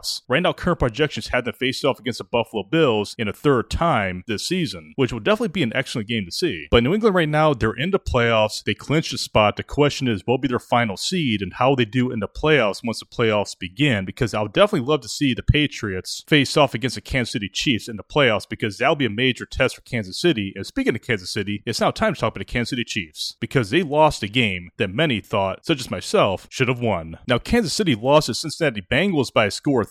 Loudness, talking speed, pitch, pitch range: -21 LUFS, 260 wpm, 120 Hz, 105-145 Hz